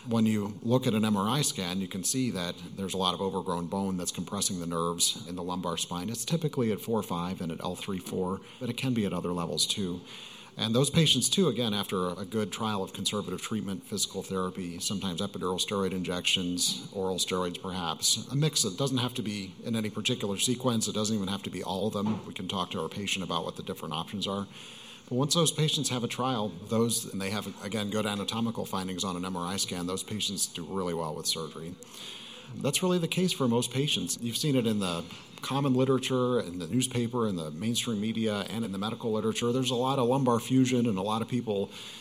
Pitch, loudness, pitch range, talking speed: 110 Hz, -30 LUFS, 95-125 Hz, 225 wpm